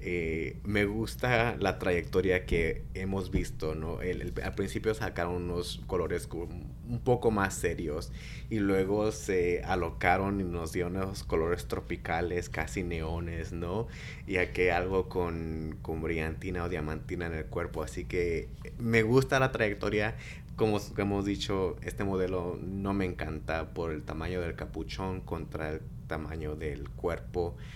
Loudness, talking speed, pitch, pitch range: -32 LUFS, 145 wpm, 90 Hz, 80-100 Hz